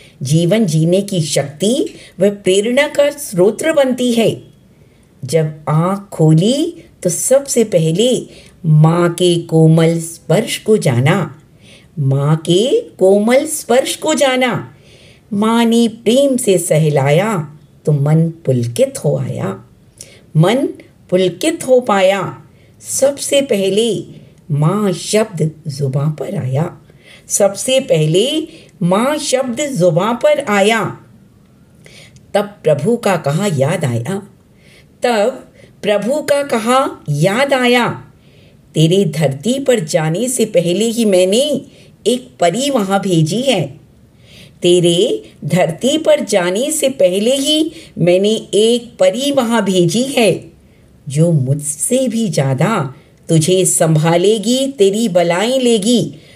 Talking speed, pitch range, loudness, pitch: 110 wpm, 165-250 Hz, -14 LUFS, 195 Hz